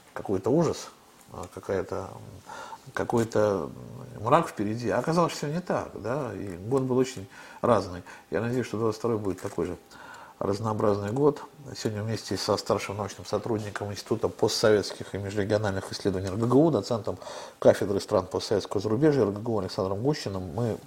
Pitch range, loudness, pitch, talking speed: 100-130 Hz, -28 LUFS, 110 Hz, 140 wpm